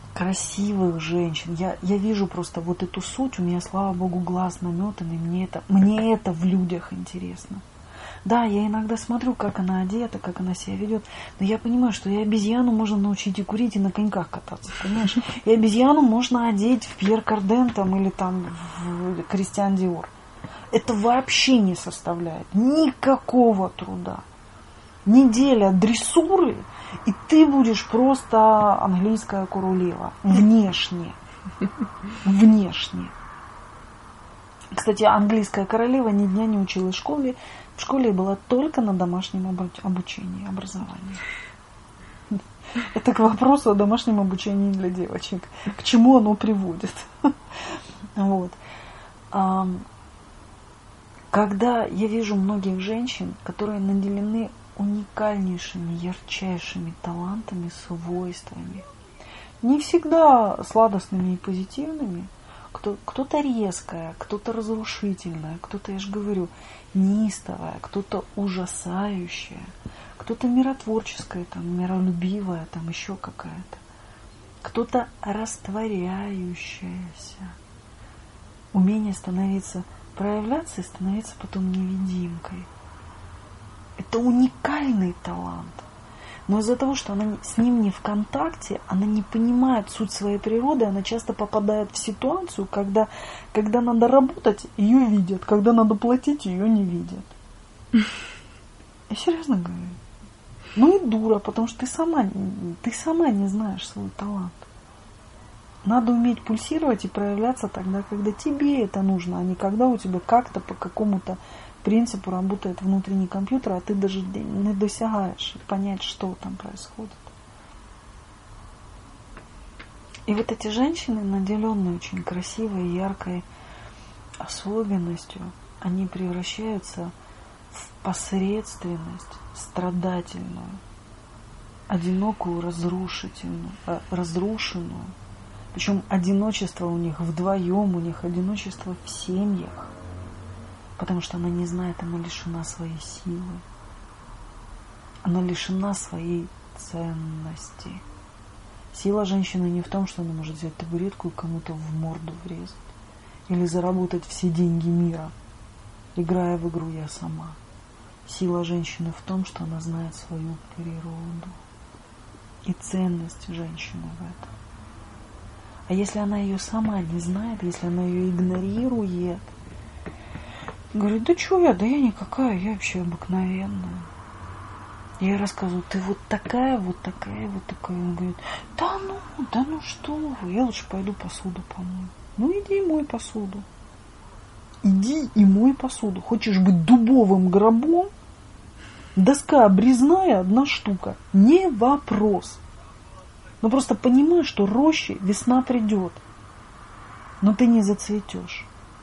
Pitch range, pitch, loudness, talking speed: 170-220 Hz, 190 Hz, -23 LUFS, 115 wpm